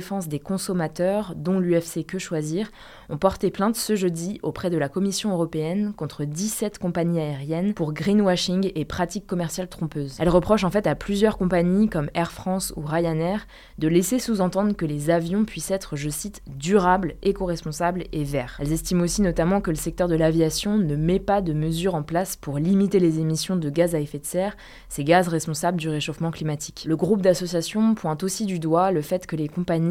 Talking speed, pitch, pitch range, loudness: 195 wpm, 175 Hz, 160-195 Hz, -24 LUFS